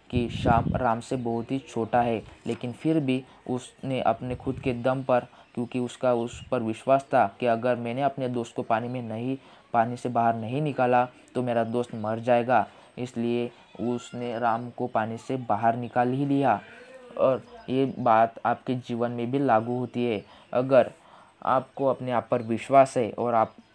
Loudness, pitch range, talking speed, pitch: -27 LUFS, 115-130 Hz, 180 wpm, 120 Hz